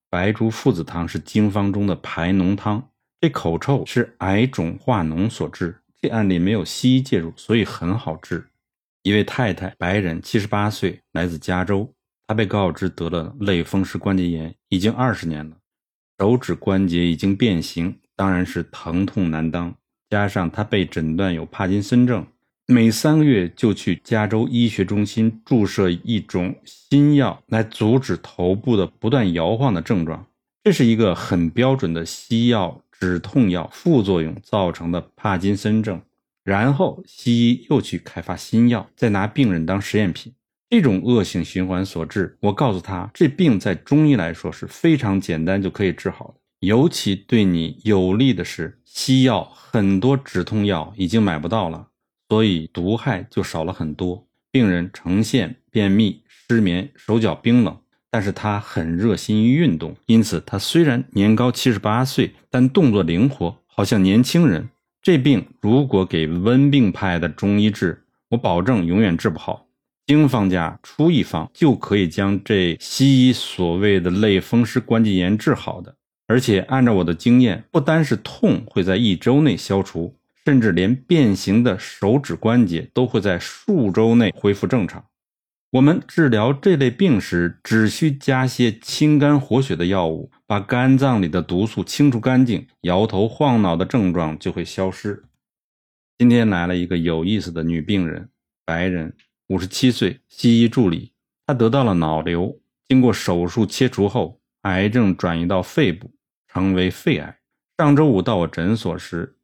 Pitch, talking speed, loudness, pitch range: 100 Hz, 245 characters per minute, -19 LUFS, 90-120 Hz